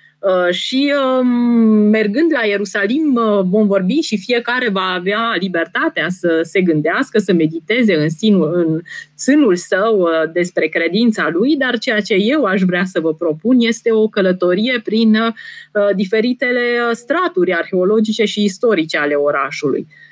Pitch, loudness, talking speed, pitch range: 210 Hz, -15 LUFS, 130 wpm, 180-240 Hz